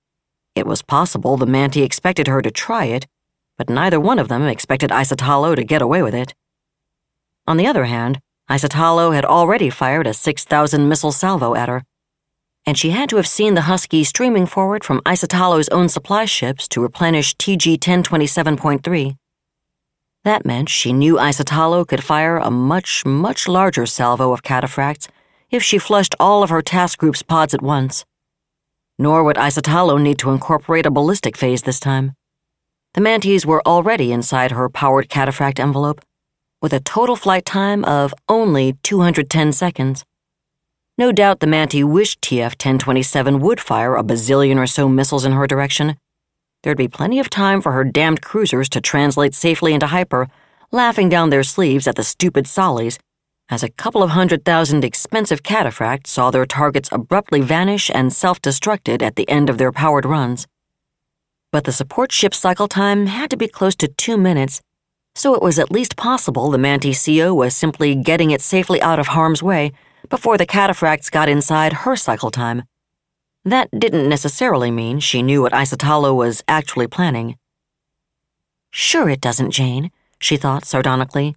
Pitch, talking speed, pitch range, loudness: 150 Hz, 170 wpm, 135-175 Hz, -16 LUFS